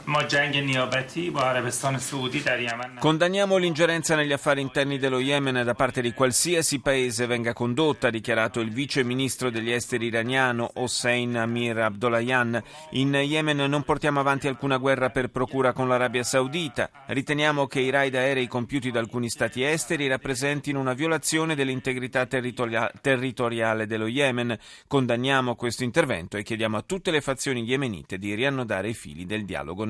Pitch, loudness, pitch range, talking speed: 130 Hz, -25 LUFS, 120-140 Hz, 145 wpm